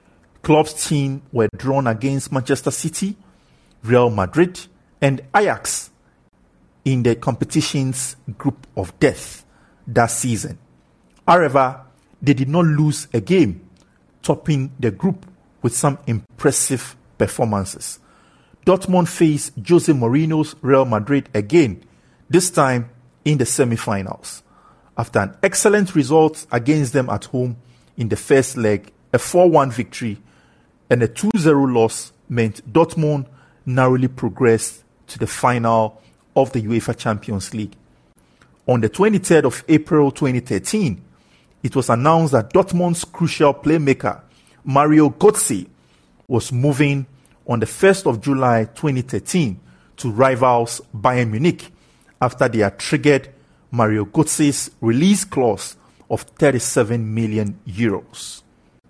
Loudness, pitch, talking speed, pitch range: -18 LUFS, 130 Hz, 115 wpm, 115-150 Hz